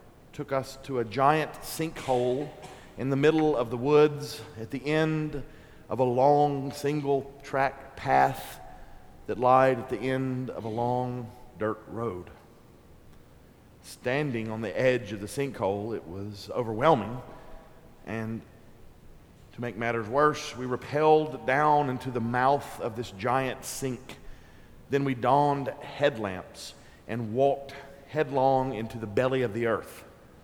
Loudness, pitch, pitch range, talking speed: -28 LUFS, 130 Hz, 115-145 Hz, 135 wpm